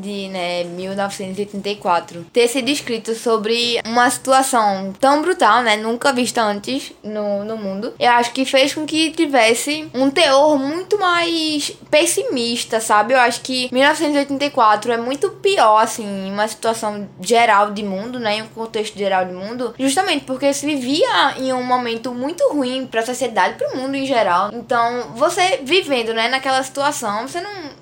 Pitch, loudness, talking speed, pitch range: 245 Hz, -17 LUFS, 165 wpm, 215-280 Hz